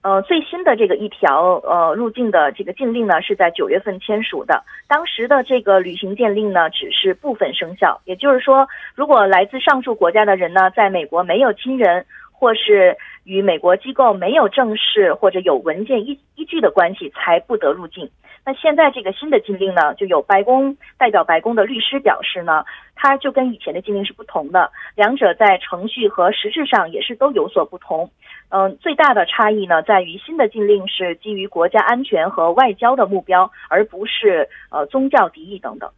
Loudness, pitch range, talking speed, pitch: -16 LUFS, 190-275 Hz, 300 characters per minute, 215 Hz